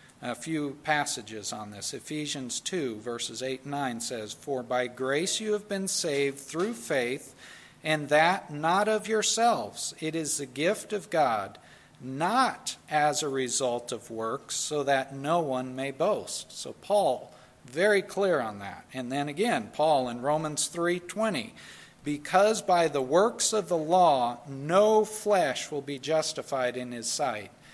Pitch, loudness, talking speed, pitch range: 150 Hz, -28 LUFS, 155 wpm, 130-185 Hz